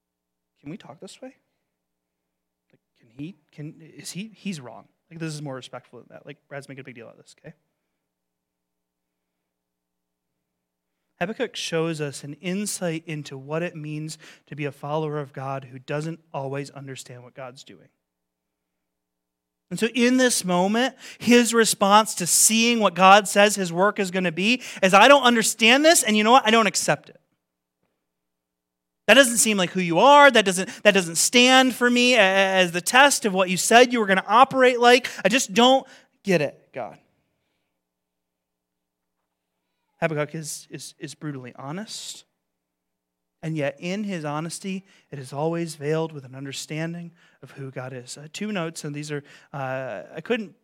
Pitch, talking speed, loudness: 155 Hz, 175 wpm, -19 LUFS